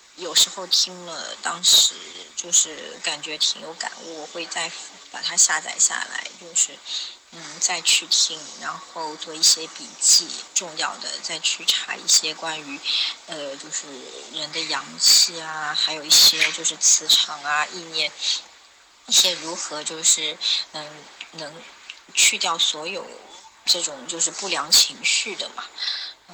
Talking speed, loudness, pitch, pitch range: 205 characters per minute, -19 LUFS, 160 Hz, 155-170 Hz